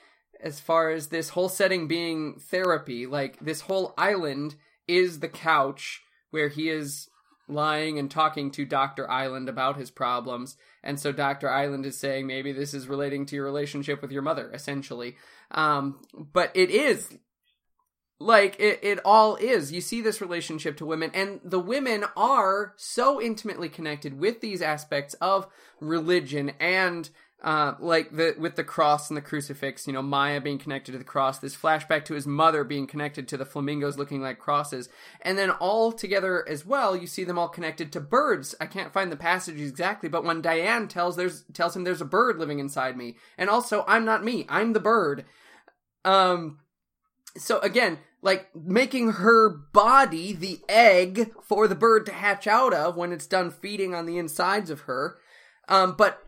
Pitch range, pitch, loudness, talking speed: 145-195 Hz, 165 Hz, -25 LUFS, 180 wpm